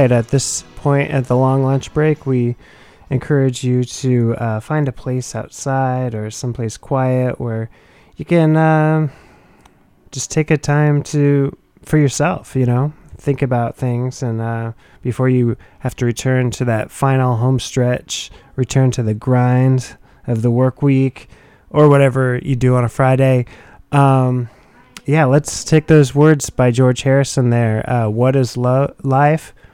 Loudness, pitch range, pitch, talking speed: -16 LUFS, 120-140 Hz, 130 Hz, 155 wpm